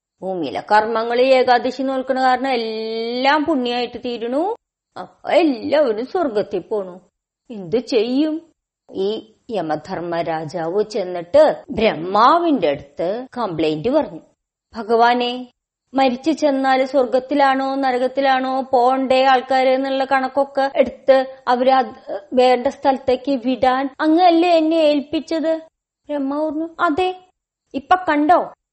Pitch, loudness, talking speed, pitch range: 265 Hz, -18 LUFS, 90 wpm, 240-295 Hz